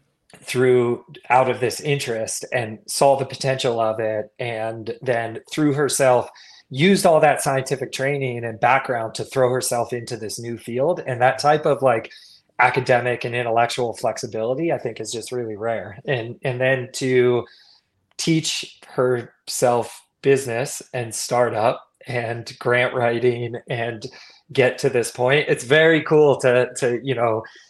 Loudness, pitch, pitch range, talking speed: -21 LUFS, 125 Hz, 115-135 Hz, 145 wpm